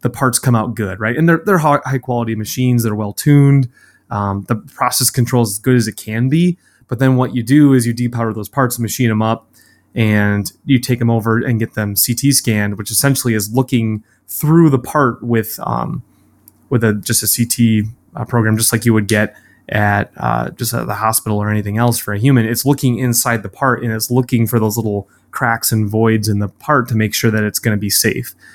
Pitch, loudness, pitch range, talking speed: 115 Hz, -15 LUFS, 110-125 Hz, 225 wpm